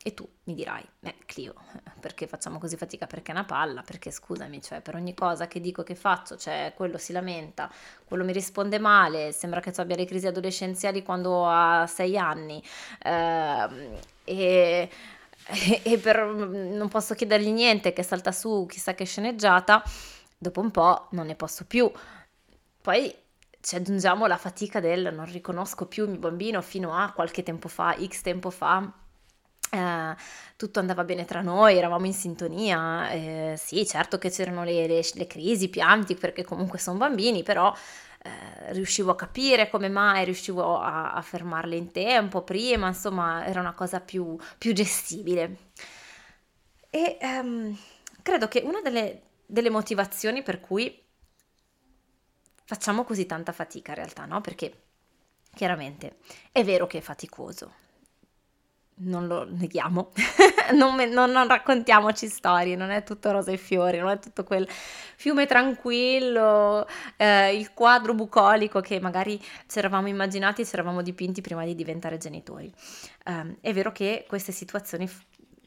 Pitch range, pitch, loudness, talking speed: 175-210 Hz, 185 Hz, -25 LUFS, 155 wpm